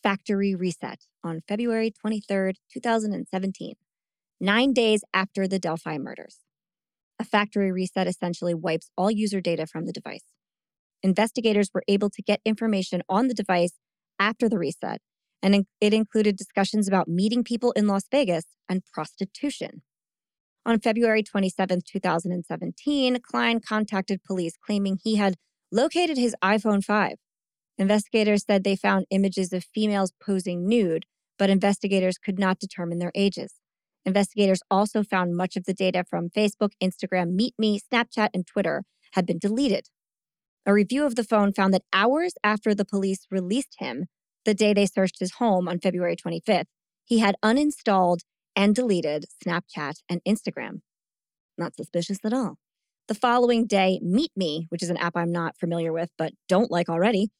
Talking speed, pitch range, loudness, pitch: 150 wpm, 185-215 Hz, -25 LUFS, 200 Hz